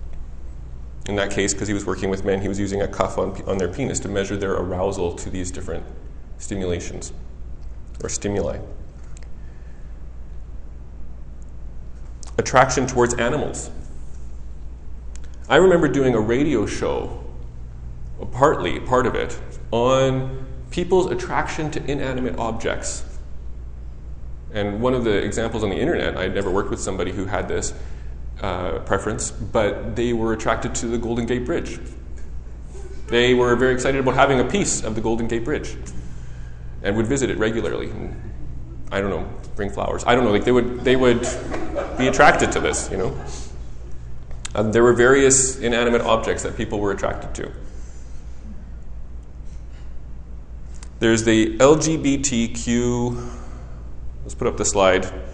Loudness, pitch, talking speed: -21 LUFS, 75 Hz, 140 wpm